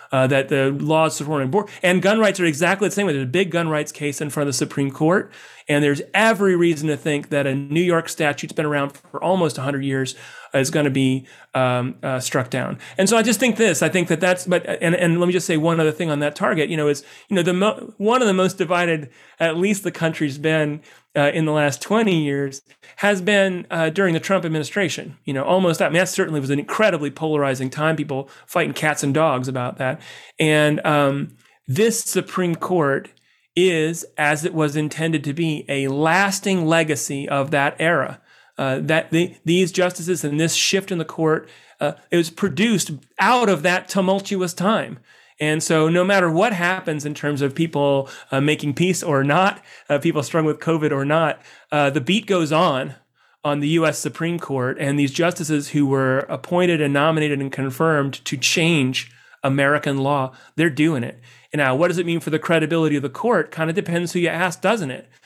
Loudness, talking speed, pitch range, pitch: -20 LUFS, 210 wpm, 145-180 Hz, 160 Hz